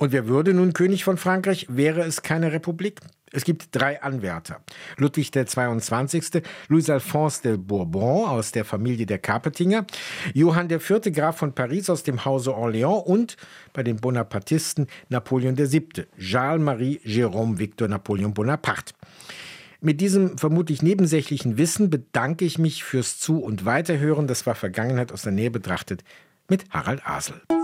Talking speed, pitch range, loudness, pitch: 140 wpm, 120-170 Hz, -23 LUFS, 145 Hz